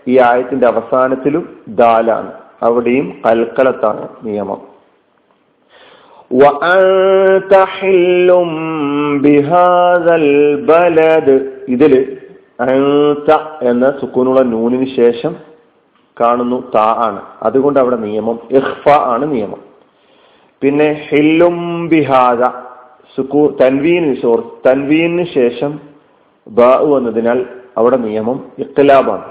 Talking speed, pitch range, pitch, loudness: 65 wpm, 125-160 Hz, 135 Hz, -12 LUFS